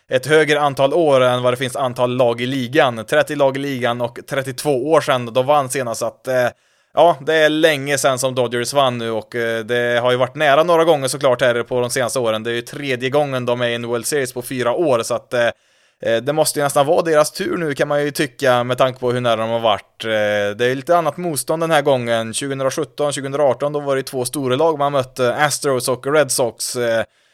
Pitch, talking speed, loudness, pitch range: 130 Hz, 240 wpm, -18 LUFS, 120-145 Hz